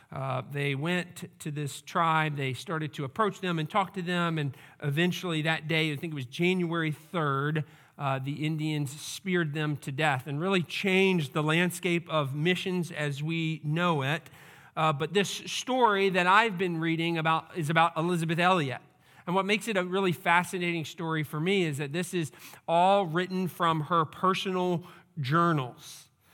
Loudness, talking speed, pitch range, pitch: -28 LUFS, 175 wpm, 150-180 Hz, 165 Hz